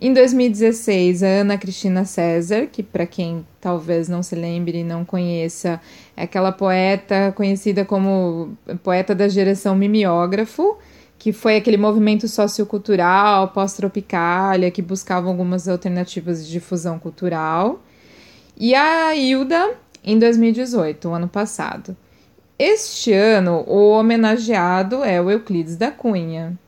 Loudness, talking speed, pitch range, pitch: -18 LUFS, 125 wpm, 180-215 Hz, 195 Hz